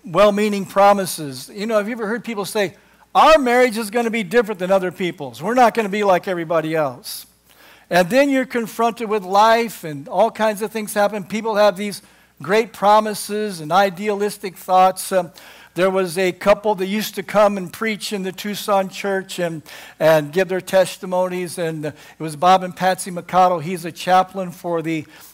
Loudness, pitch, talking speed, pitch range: -18 LUFS, 195 Hz, 190 wpm, 180-215 Hz